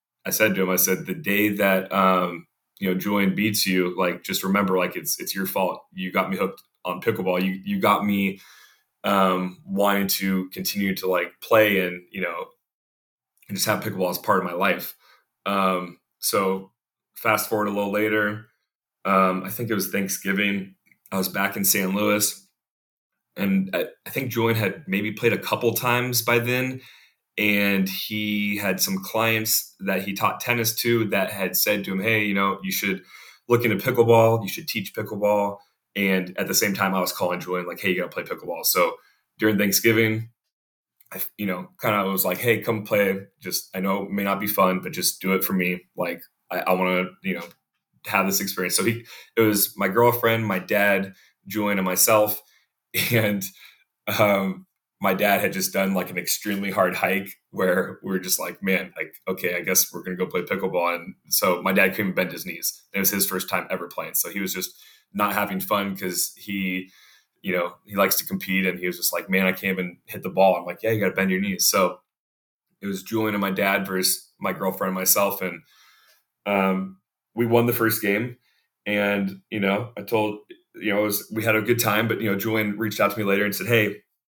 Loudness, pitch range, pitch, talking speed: -23 LUFS, 95-110 Hz, 100 Hz, 210 wpm